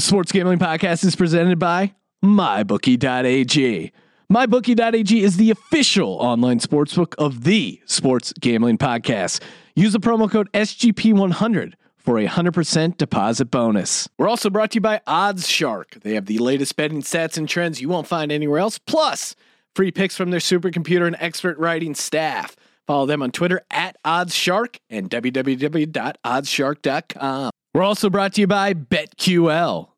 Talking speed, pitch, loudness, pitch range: 150 wpm, 175 Hz, -19 LUFS, 145-200 Hz